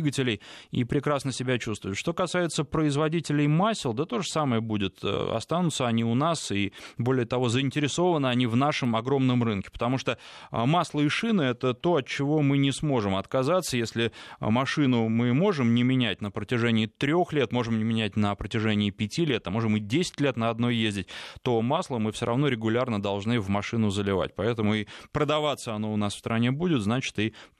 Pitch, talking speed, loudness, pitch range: 125 Hz, 185 wpm, -26 LUFS, 110-145 Hz